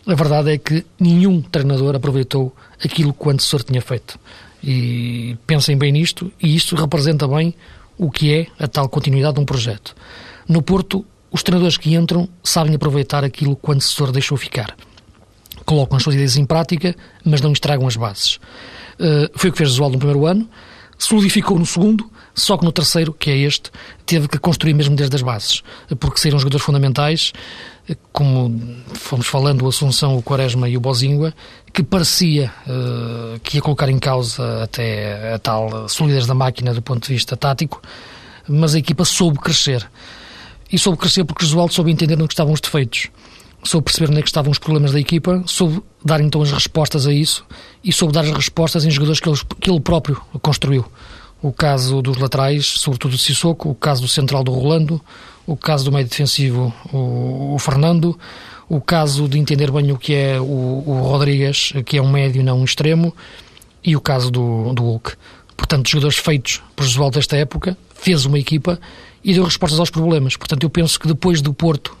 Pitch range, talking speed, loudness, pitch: 130-160 Hz, 195 wpm, -16 LUFS, 145 Hz